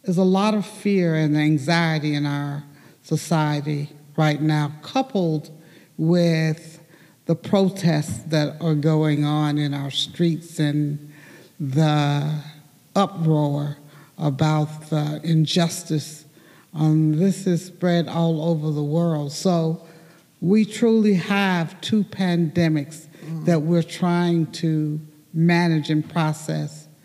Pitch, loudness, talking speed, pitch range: 160 Hz, -22 LUFS, 110 wpm, 150-170 Hz